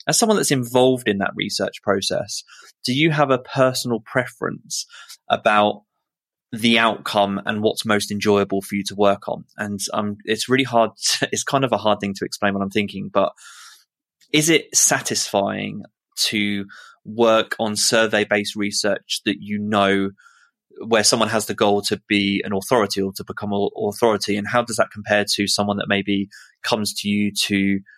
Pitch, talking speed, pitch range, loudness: 105 Hz, 180 wpm, 100-115 Hz, -20 LUFS